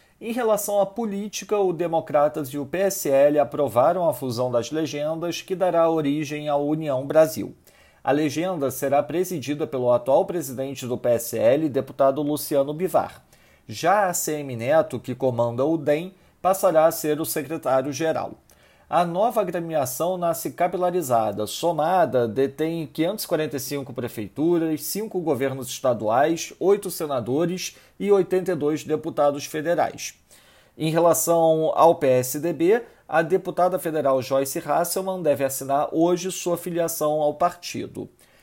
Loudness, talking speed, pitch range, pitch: -23 LUFS, 125 wpm, 140-175 Hz, 155 Hz